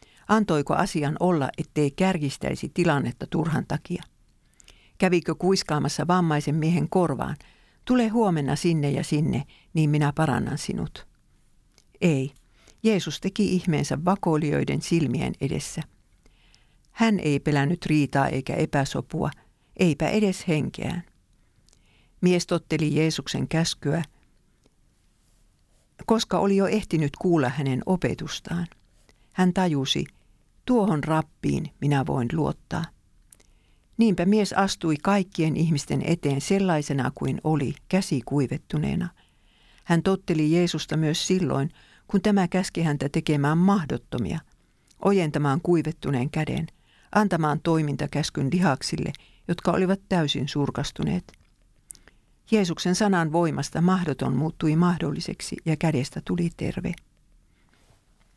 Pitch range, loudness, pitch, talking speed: 140-180 Hz, -25 LUFS, 160 Hz, 100 wpm